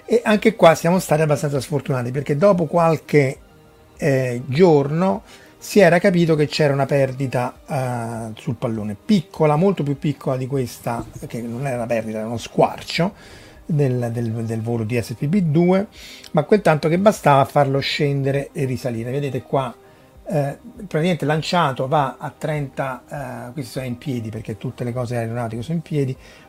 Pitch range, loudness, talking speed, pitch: 125-160 Hz, -20 LUFS, 165 wpm, 140 Hz